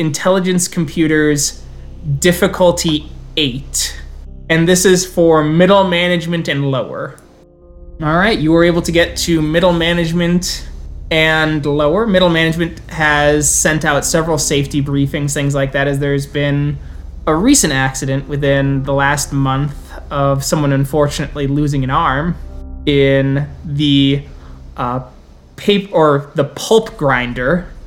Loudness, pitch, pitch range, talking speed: -14 LUFS, 145 Hz, 140-170 Hz, 125 wpm